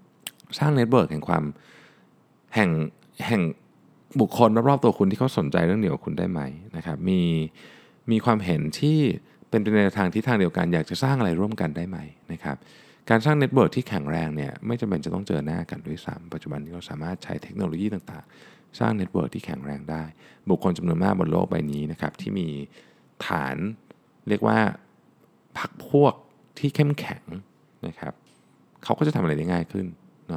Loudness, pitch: -25 LUFS, 110 Hz